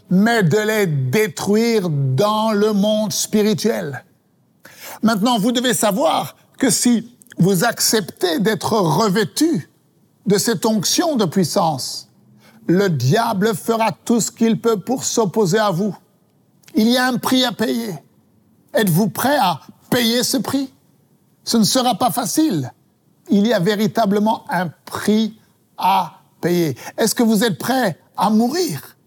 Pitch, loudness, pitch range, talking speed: 220 Hz, -18 LUFS, 205-235 Hz, 140 wpm